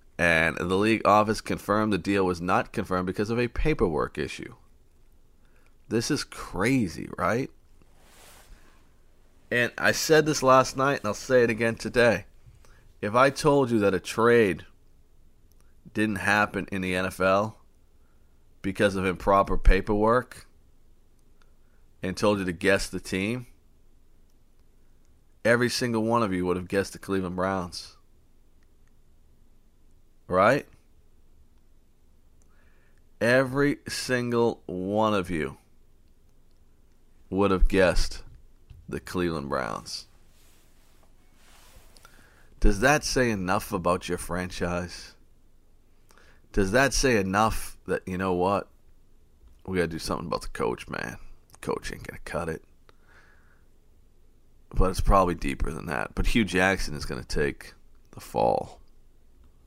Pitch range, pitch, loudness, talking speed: 85-110 Hz, 95 Hz, -26 LUFS, 120 wpm